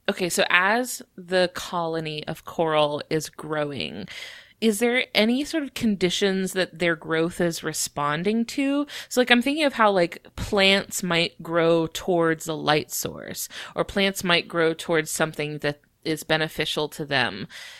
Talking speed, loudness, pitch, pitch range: 155 wpm, -24 LUFS, 170 Hz, 155-215 Hz